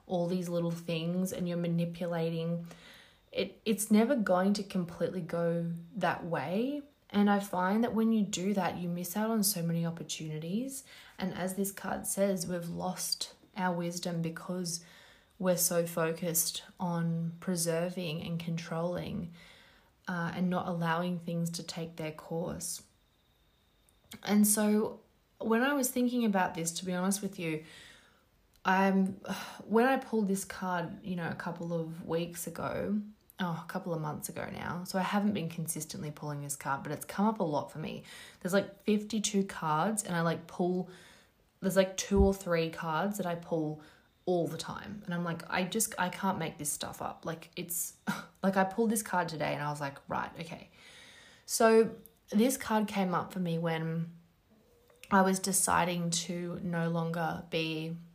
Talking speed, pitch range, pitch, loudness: 170 wpm, 170-195 Hz, 180 Hz, -33 LUFS